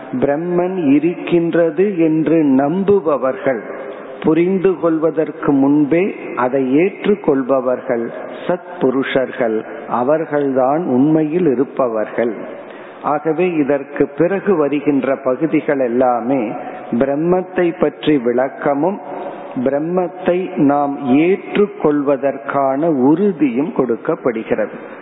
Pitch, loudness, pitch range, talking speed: 150 Hz, -16 LUFS, 135-175 Hz, 70 wpm